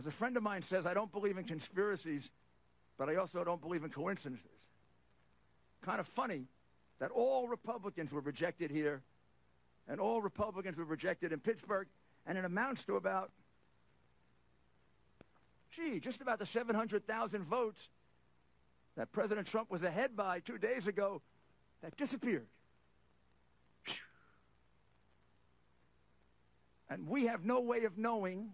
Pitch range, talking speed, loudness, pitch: 160-225 Hz, 130 wpm, -39 LUFS, 195 Hz